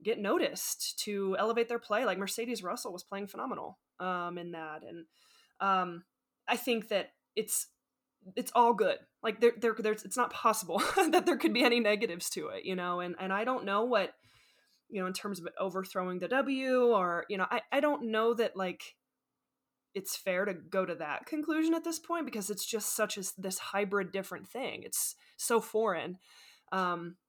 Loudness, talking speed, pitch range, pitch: -32 LUFS, 190 wpm, 190-240 Hz, 210 Hz